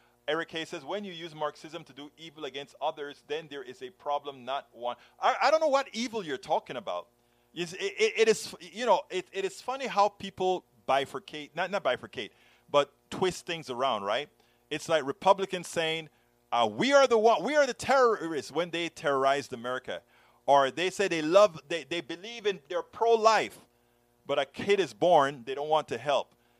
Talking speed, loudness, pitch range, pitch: 195 wpm, -29 LUFS, 140-210 Hz, 170 Hz